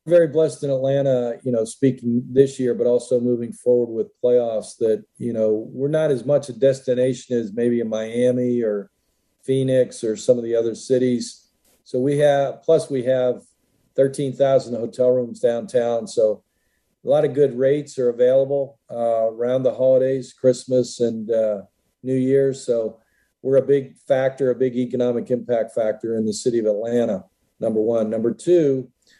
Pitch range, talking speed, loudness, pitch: 115-135 Hz, 170 wpm, -21 LUFS, 125 Hz